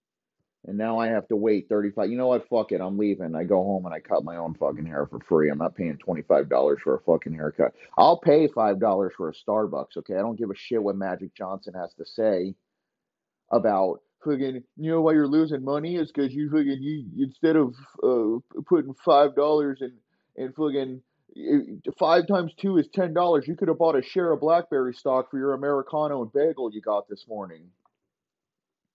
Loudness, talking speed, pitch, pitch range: -25 LUFS, 200 wpm, 140 Hz, 110-160 Hz